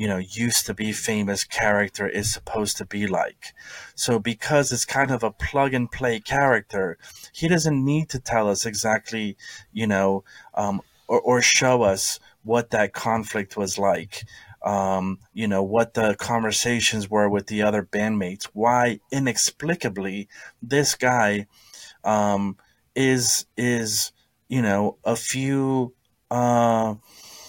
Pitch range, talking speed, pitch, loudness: 105-125 Hz, 135 wpm, 110 Hz, -23 LUFS